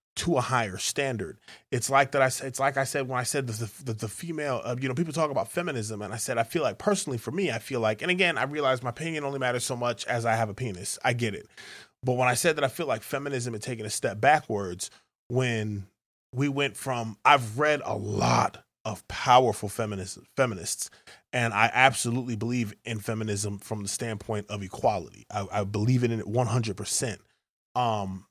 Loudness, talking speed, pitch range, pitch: -28 LUFS, 215 wpm, 110-135 Hz, 120 Hz